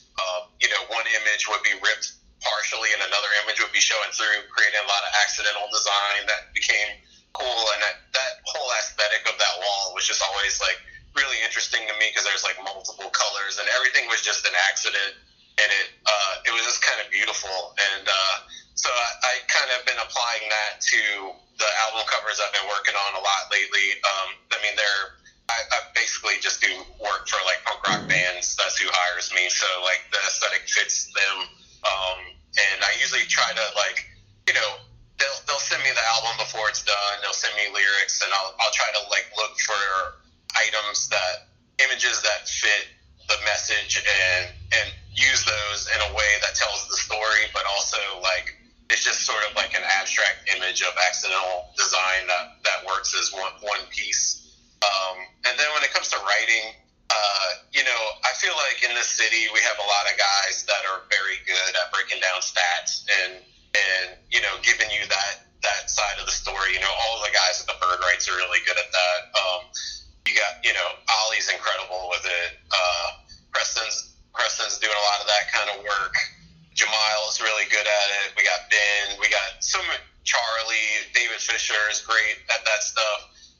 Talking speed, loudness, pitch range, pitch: 195 wpm, -22 LUFS, 90-105 Hz, 100 Hz